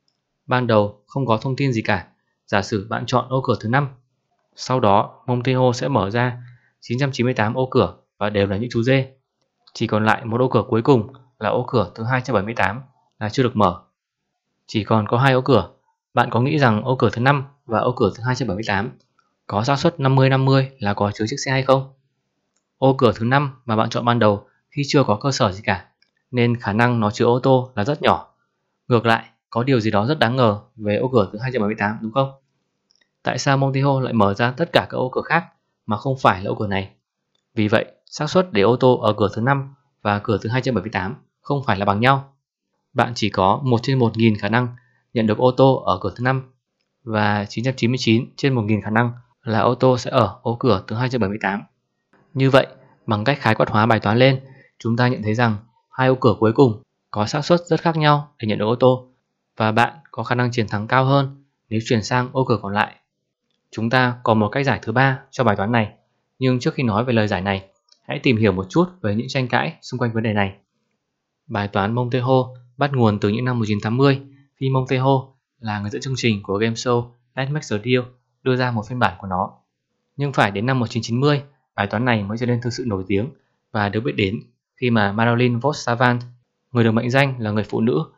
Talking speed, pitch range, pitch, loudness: 230 wpm, 110-130 Hz, 120 Hz, -20 LUFS